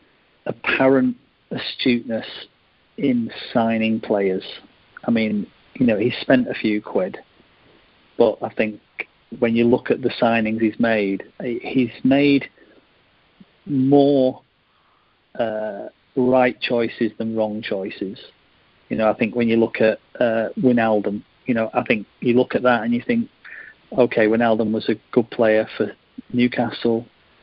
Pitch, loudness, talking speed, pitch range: 115 Hz, -20 LUFS, 140 wpm, 110-125 Hz